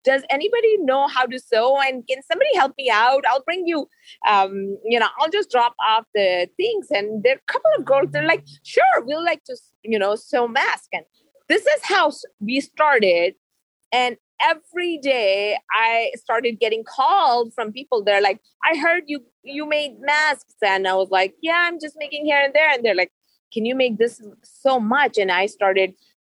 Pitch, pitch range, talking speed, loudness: 260 Hz, 215-305 Hz, 200 wpm, -19 LUFS